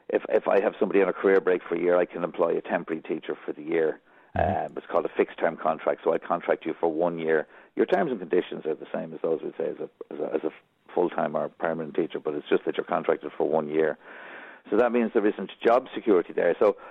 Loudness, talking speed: -26 LUFS, 260 wpm